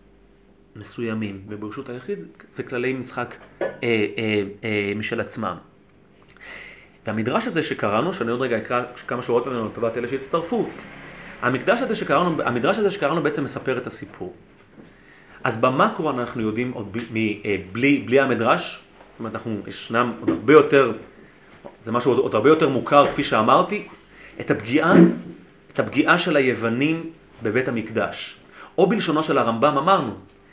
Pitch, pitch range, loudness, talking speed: 125 Hz, 110-145 Hz, -21 LUFS, 140 wpm